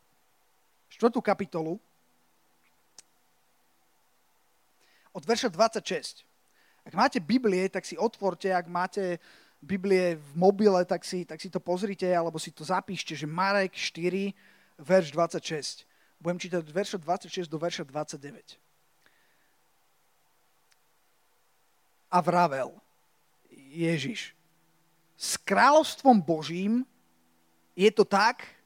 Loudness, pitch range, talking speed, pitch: -28 LUFS, 165-200 Hz, 100 wpm, 180 Hz